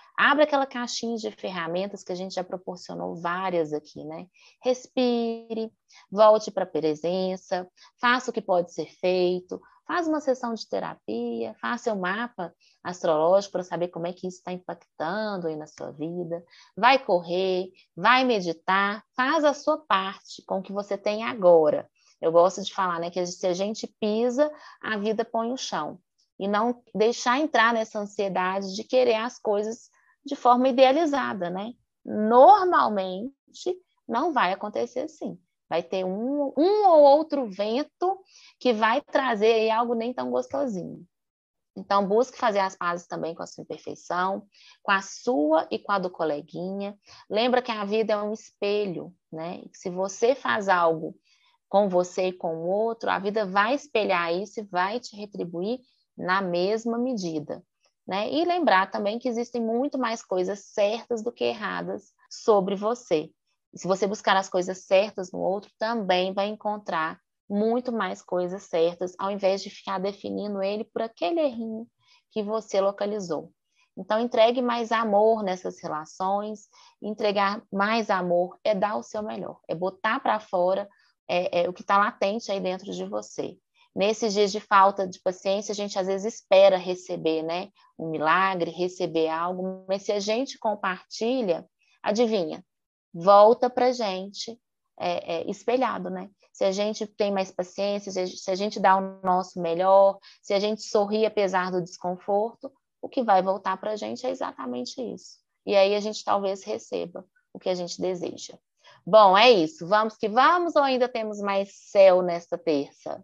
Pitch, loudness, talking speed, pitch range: 205 Hz, -25 LUFS, 165 wpm, 185-235 Hz